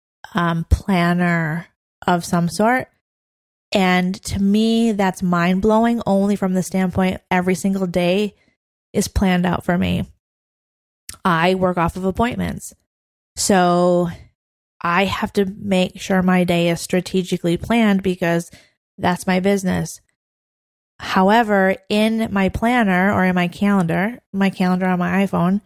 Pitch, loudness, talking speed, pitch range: 185 Hz, -18 LUFS, 130 wpm, 175-200 Hz